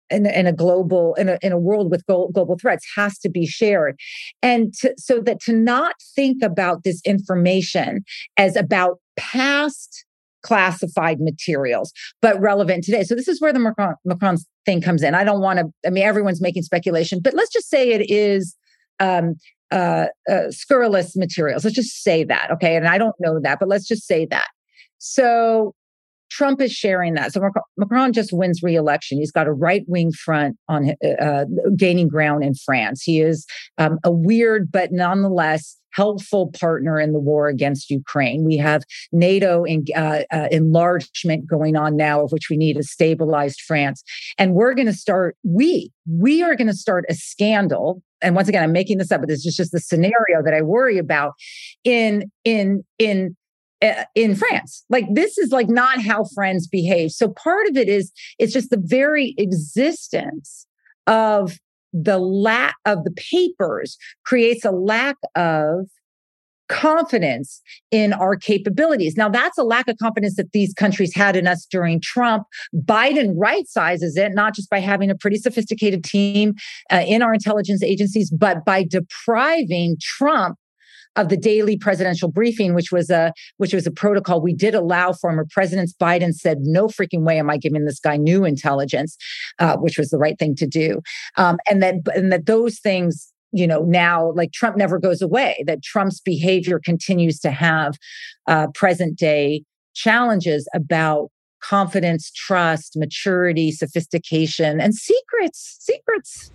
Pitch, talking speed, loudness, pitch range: 185 Hz, 170 wpm, -18 LUFS, 165-215 Hz